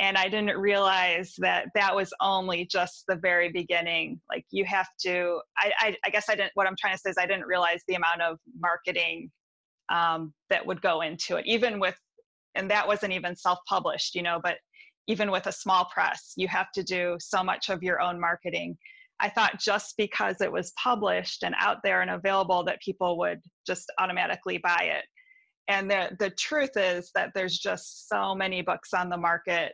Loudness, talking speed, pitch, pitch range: -27 LUFS, 195 wpm, 185 Hz, 175-200 Hz